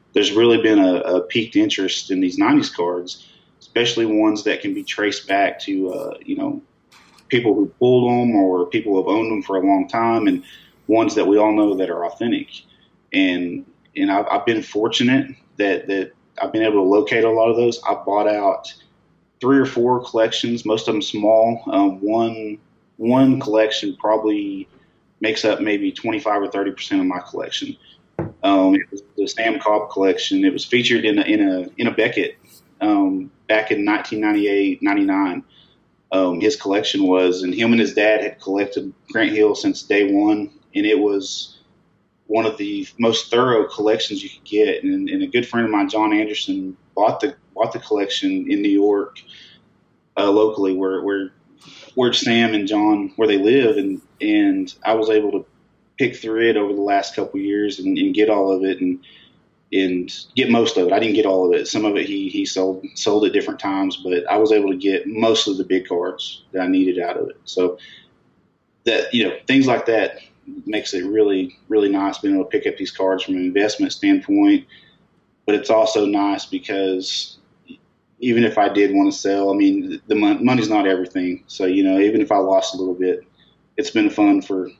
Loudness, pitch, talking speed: -19 LUFS, 115 Hz, 200 wpm